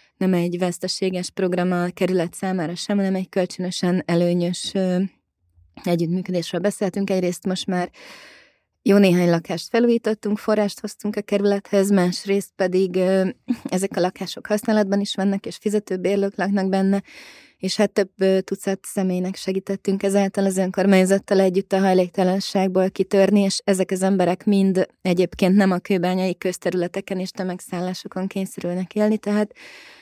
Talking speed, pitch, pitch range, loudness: 130 wpm, 190 Hz, 180-200 Hz, -21 LUFS